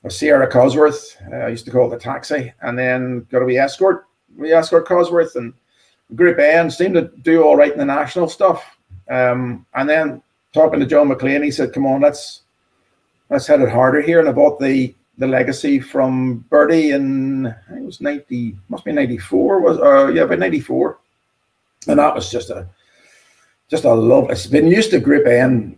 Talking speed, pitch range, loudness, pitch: 200 wpm, 125-160 Hz, -15 LUFS, 140 Hz